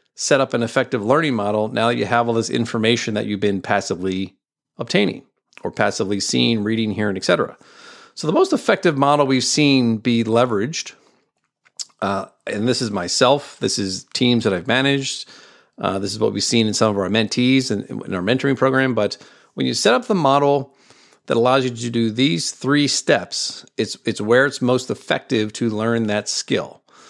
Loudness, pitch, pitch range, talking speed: -19 LUFS, 120 Hz, 105-135 Hz, 190 wpm